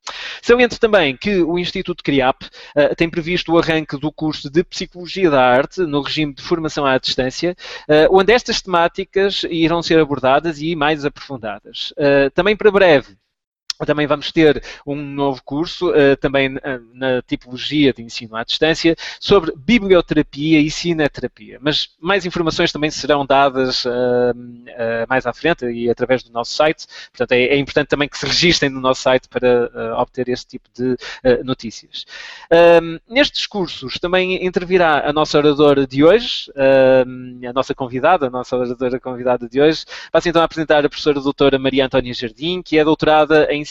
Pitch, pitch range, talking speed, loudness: 145 Hz, 130-165 Hz, 170 wpm, -16 LUFS